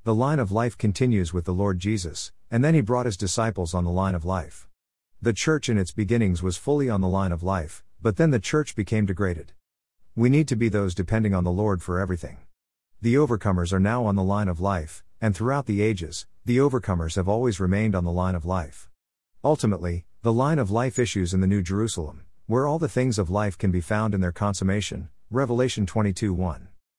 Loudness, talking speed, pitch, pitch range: -24 LUFS, 215 wpm, 100 Hz, 90-115 Hz